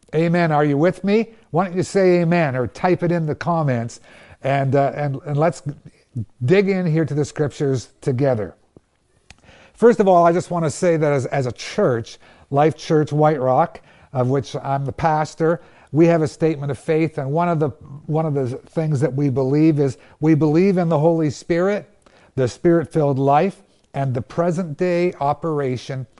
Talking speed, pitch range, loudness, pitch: 190 wpm, 140-170 Hz, -19 LUFS, 155 Hz